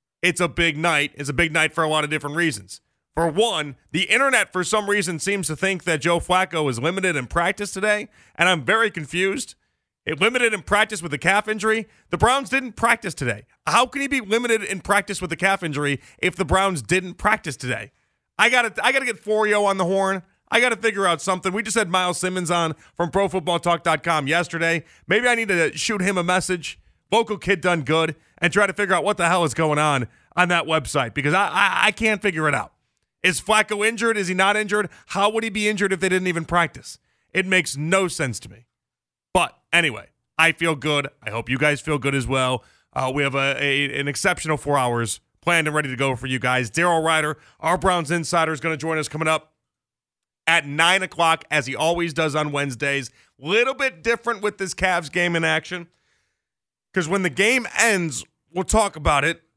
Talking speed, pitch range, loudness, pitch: 220 wpm, 155-200 Hz, -21 LUFS, 175 Hz